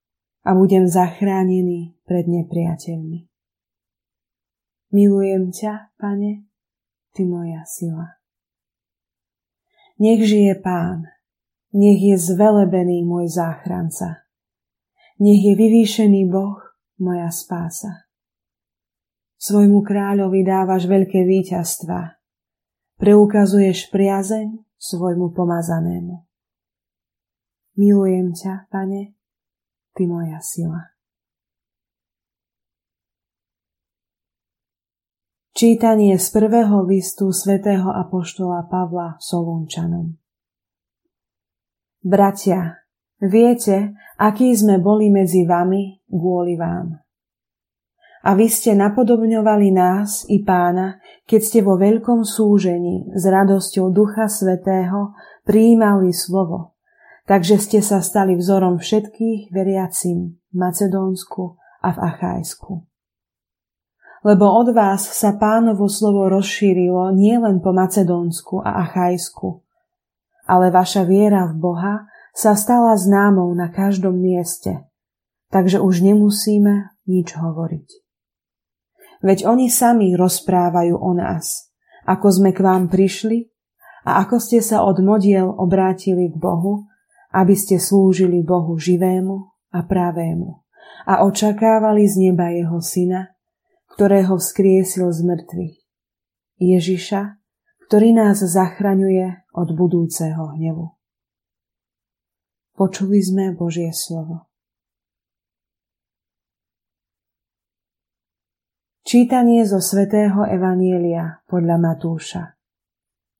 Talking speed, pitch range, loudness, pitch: 90 wpm, 175-205 Hz, -16 LUFS, 190 Hz